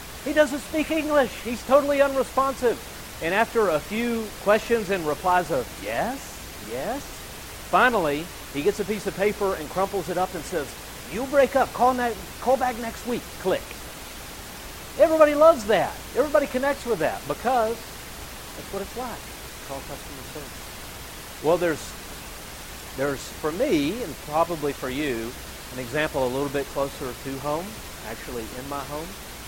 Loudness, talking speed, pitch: -25 LUFS, 155 wpm, 205 Hz